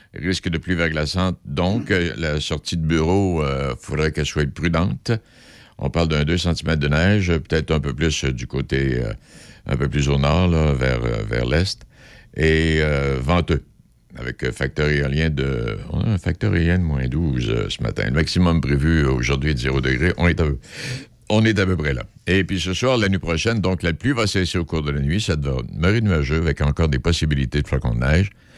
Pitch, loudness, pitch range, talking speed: 80 Hz, -21 LUFS, 70-90 Hz, 215 wpm